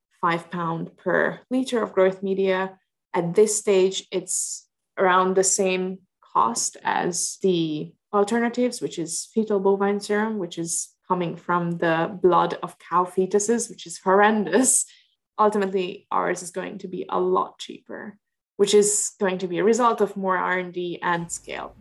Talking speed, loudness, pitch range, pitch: 155 wpm, -23 LUFS, 180-205 Hz, 190 Hz